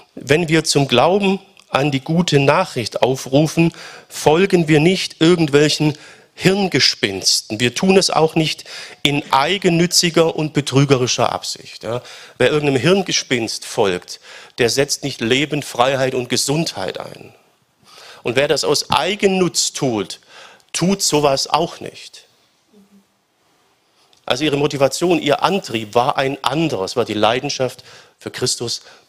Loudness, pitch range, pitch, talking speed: -17 LUFS, 130-170 Hz, 145 Hz, 125 wpm